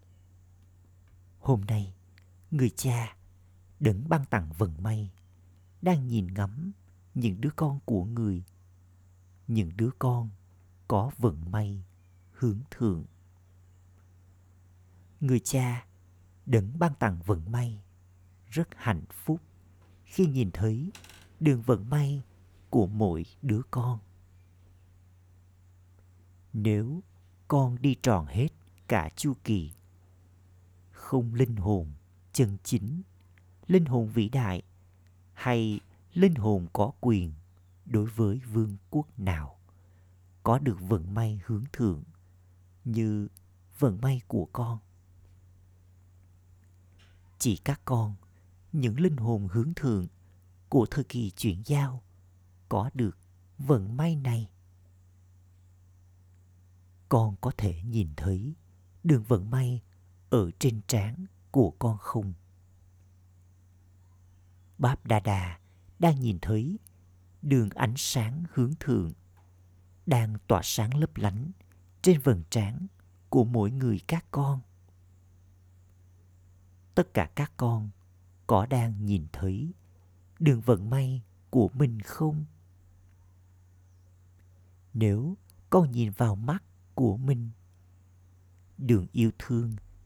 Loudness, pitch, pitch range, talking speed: -29 LUFS, 95 Hz, 90-120 Hz, 110 wpm